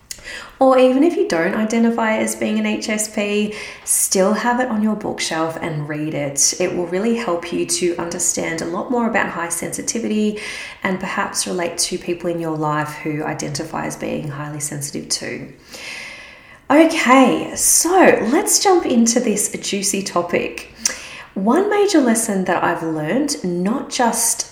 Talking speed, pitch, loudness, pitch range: 155 wpm, 200 Hz, -18 LUFS, 170-240 Hz